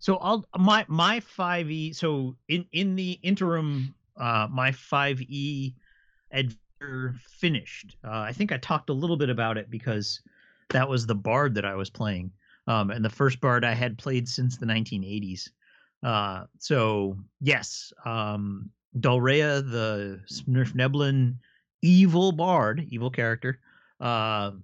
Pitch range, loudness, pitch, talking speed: 110-150 Hz, -26 LUFS, 130 Hz, 150 wpm